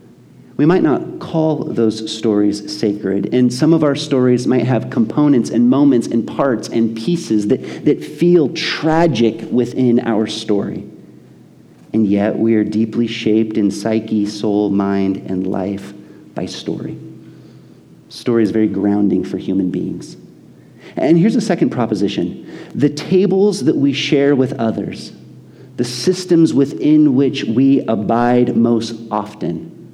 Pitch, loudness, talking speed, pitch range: 115 Hz, -16 LUFS, 140 wpm, 105-140 Hz